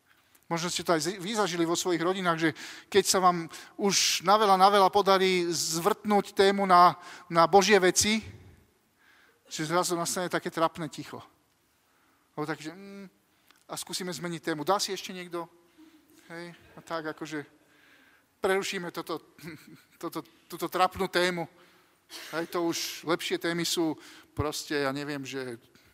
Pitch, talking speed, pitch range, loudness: 175 Hz, 145 wpm, 160-190 Hz, -27 LUFS